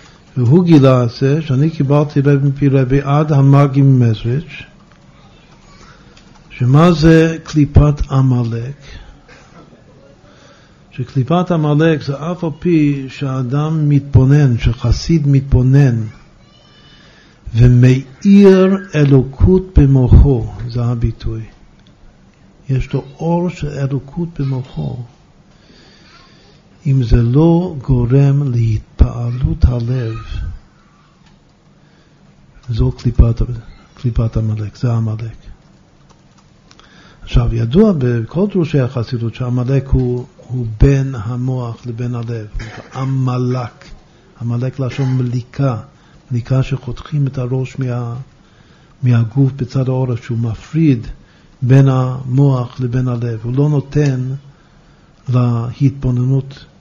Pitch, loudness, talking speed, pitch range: 130 Hz, -14 LUFS, 90 wpm, 120-145 Hz